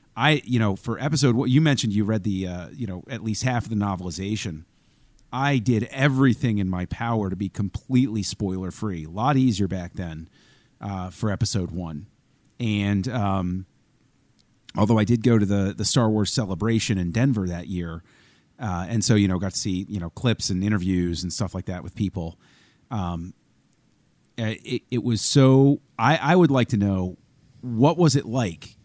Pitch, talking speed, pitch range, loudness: 105 Hz, 185 wpm, 95-125 Hz, -23 LUFS